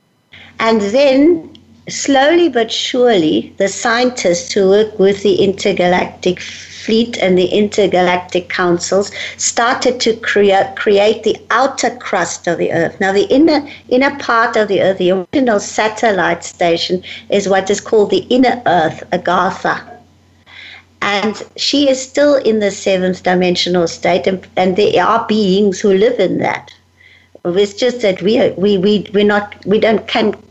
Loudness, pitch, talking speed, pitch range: -13 LUFS, 205 Hz, 150 wpm, 190-245 Hz